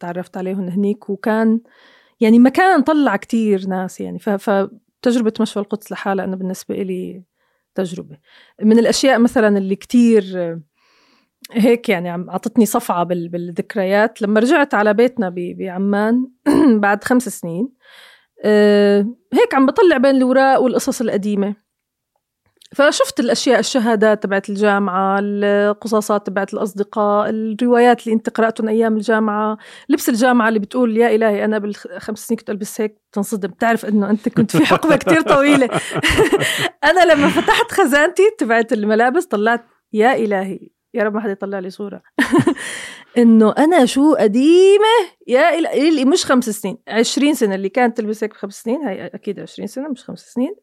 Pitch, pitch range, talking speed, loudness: 220 Hz, 205-255 Hz, 140 wpm, -16 LUFS